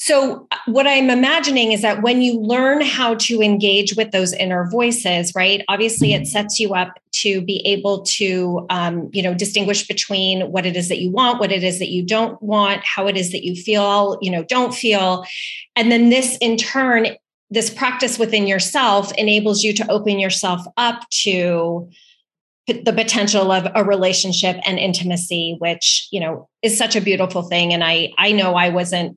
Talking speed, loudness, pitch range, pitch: 185 wpm, -17 LUFS, 185-225 Hz, 200 Hz